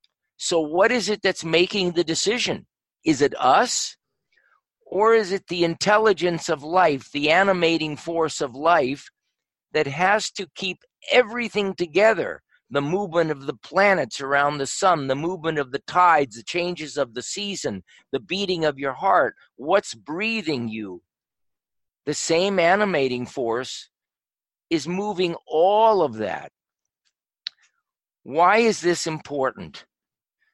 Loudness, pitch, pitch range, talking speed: -22 LUFS, 175 Hz, 150-195 Hz, 135 wpm